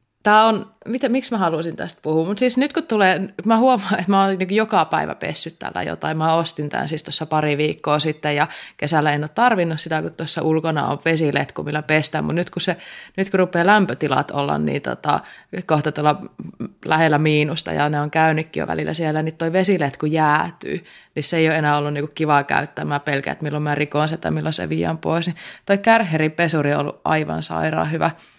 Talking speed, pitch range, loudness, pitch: 205 wpm, 150-190 Hz, -20 LUFS, 160 Hz